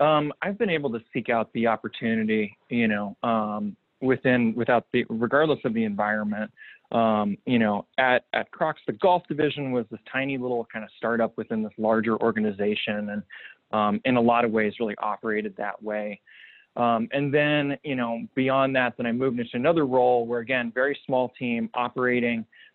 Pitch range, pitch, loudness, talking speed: 110-130 Hz, 115 Hz, -25 LUFS, 180 wpm